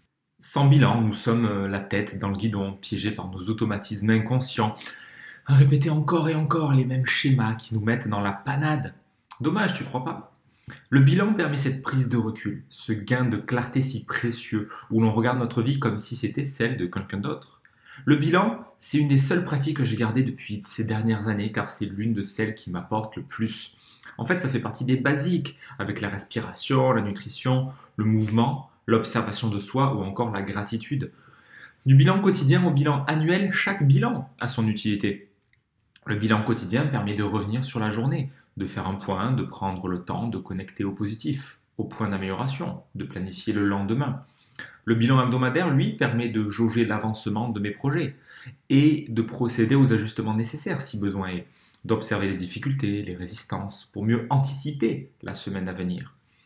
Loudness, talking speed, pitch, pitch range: -25 LUFS, 185 wpm, 115 Hz, 105-135 Hz